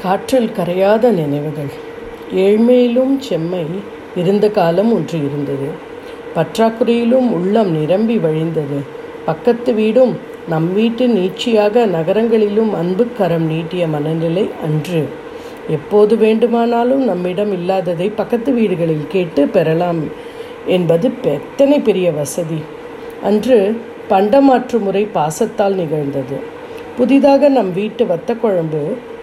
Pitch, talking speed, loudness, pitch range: 205 Hz, 90 wpm, -15 LUFS, 165-240 Hz